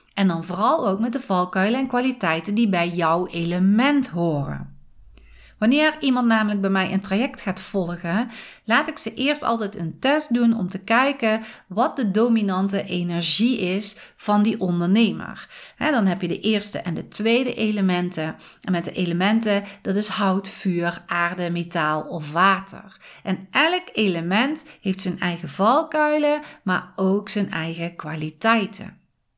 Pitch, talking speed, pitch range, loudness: 195 Hz, 155 wpm, 175-225 Hz, -22 LUFS